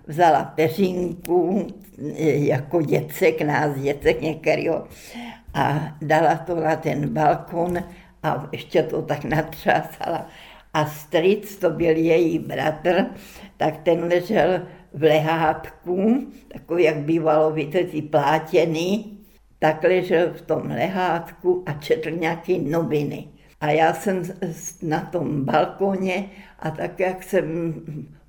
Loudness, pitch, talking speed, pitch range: -22 LUFS, 165 Hz, 110 wpm, 155-180 Hz